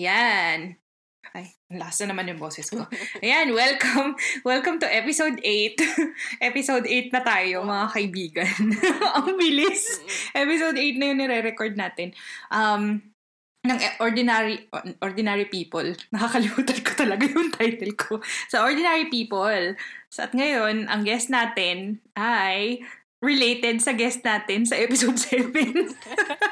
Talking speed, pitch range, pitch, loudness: 130 wpm, 205-275 Hz, 235 Hz, -23 LUFS